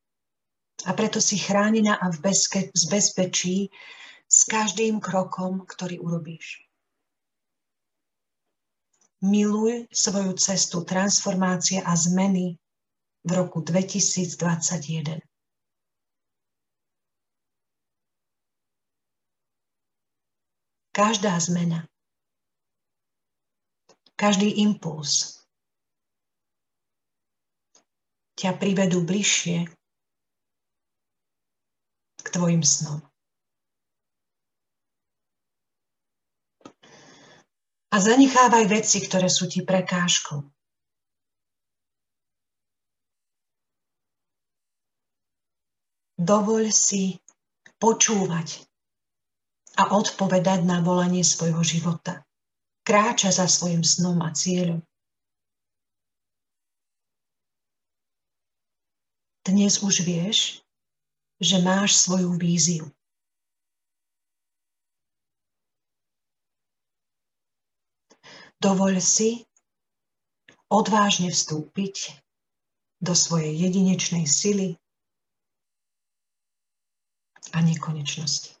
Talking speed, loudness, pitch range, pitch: 55 wpm, -22 LUFS, 165-200 Hz, 180 Hz